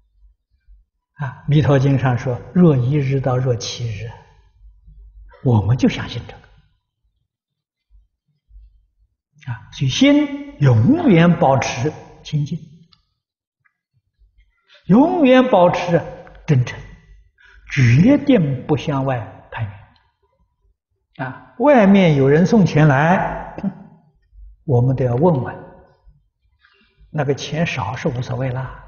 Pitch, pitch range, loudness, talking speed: 135 Hz, 115-165 Hz, -16 LUFS, 135 characters per minute